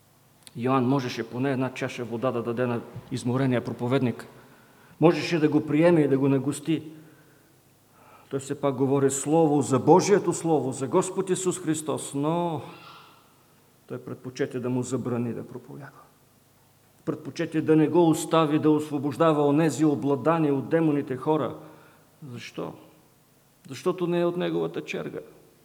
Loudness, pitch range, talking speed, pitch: -25 LUFS, 130-155 Hz, 135 wpm, 140 Hz